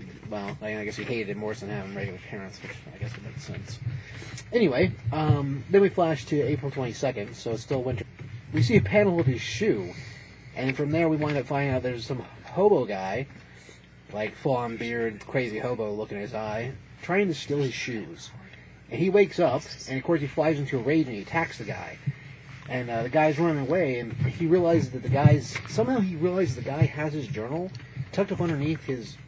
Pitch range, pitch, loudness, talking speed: 115-150 Hz, 130 Hz, -27 LUFS, 210 wpm